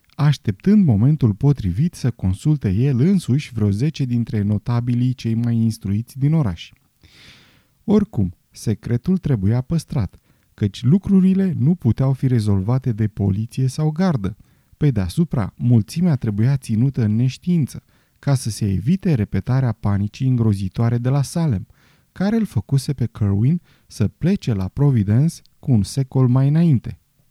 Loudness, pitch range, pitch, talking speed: -19 LUFS, 110-150 Hz, 125 Hz, 135 wpm